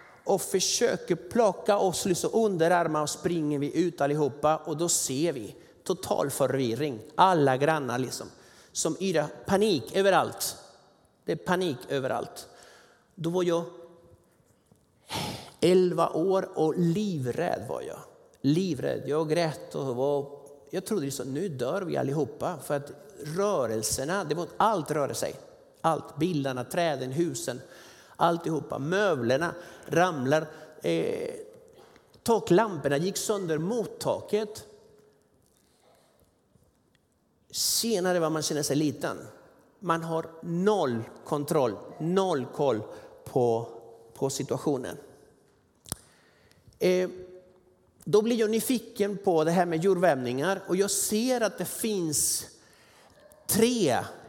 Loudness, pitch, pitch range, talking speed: -28 LUFS, 170 Hz, 145-195 Hz, 115 wpm